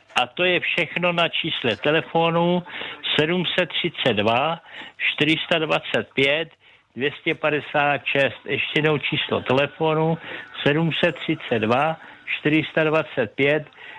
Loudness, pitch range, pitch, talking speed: -21 LUFS, 145-170 Hz, 155 Hz, 70 wpm